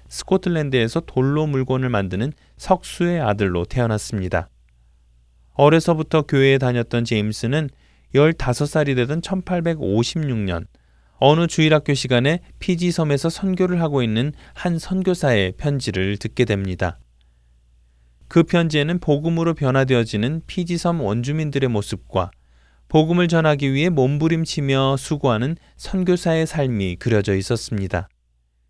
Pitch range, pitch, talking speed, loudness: 100-160 Hz, 135 Hz, 290 characters per minute, -20 LUFS